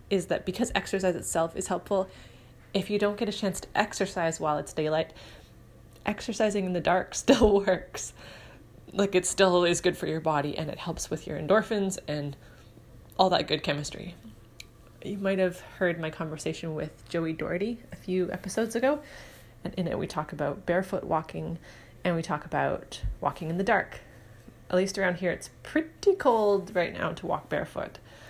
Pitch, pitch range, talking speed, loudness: 175 Hz, 150-195 Hz, 180 wpm, -29 LUFS